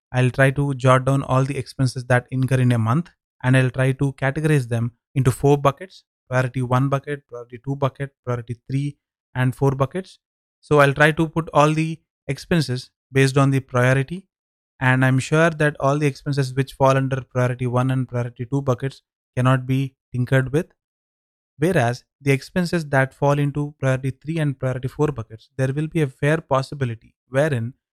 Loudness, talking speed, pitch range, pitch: -21 LUFS, 180 wpm, 130-145 Hz, 135 Hz